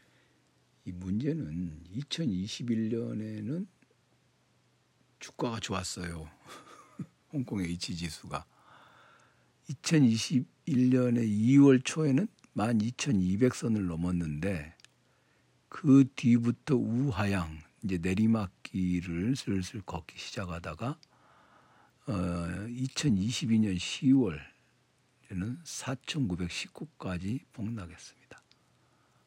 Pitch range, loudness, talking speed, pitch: 90-125 Hz, -31 LUFS, 140 characters per minute, 110 Hz